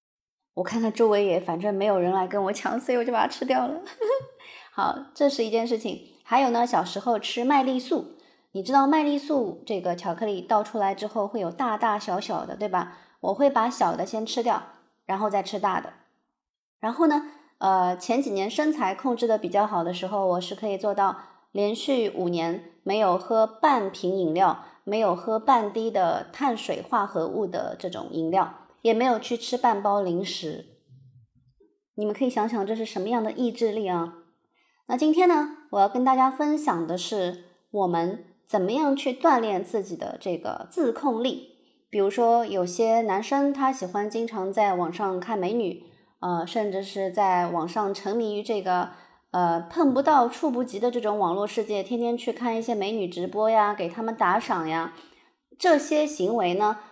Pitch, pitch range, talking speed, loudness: 215 Hz, 190-250 Hz, 265 characters per minute, -25 LUFS